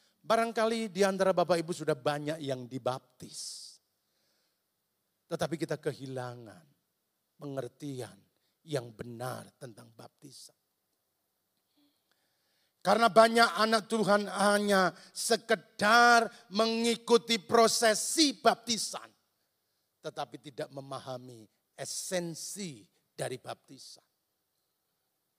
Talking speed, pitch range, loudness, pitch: 75 wpm, 140-225 Hz, -29 LUFS, 180 Hz